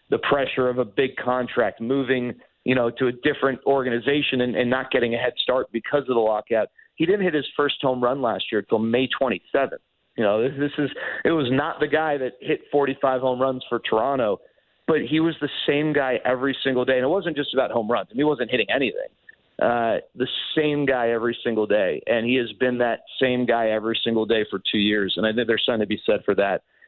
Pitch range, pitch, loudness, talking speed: 120-145 Hz, 130 Hz, -23 LUFS, 240 wpm